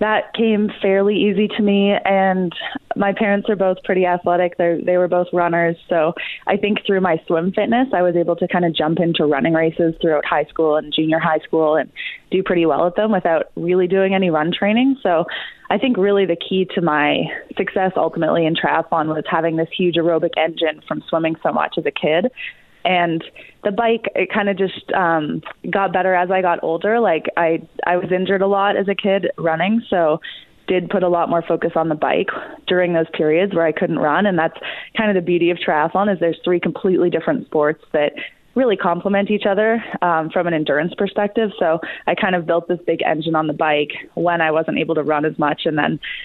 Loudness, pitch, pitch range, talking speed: -18 LUFS, 180 Hz, 165-195 Hz, 215 wpm